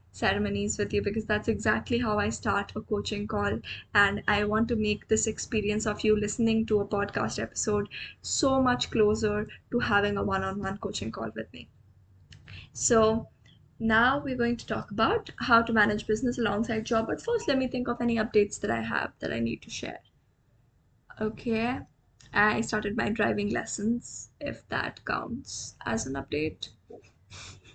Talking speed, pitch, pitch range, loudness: 175 wpm, 210 Hz, 200-225 Hz, -28 LUFS